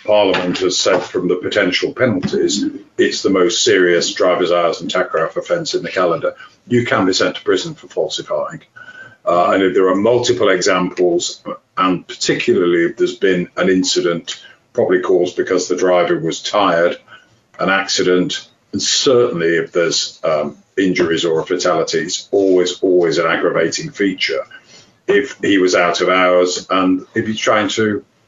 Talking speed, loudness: 155 wpm, -15 LUFS